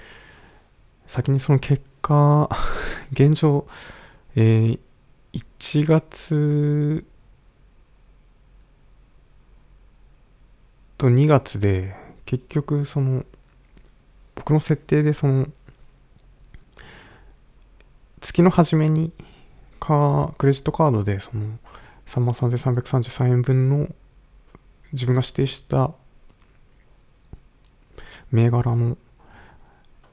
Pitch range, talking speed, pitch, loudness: 125-150 Hz, 100 characters per minute, 135 Hz, -21 LUFS